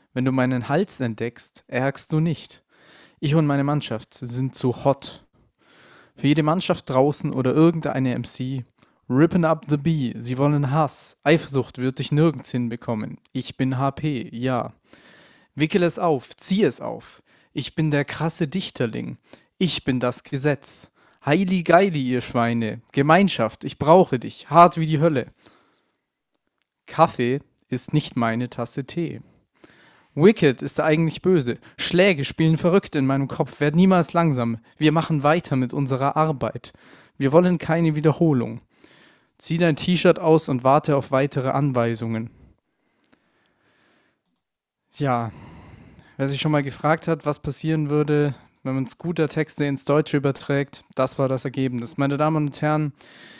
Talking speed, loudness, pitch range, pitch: 145 wpm, -22 LUFS, 125-160 Hz, 140 Hz